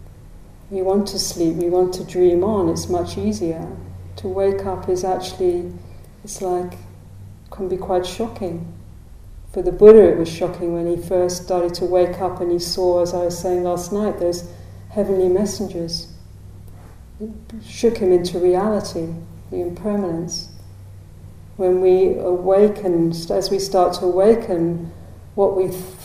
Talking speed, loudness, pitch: 150 wpm, -19 LUFS, 175 Hz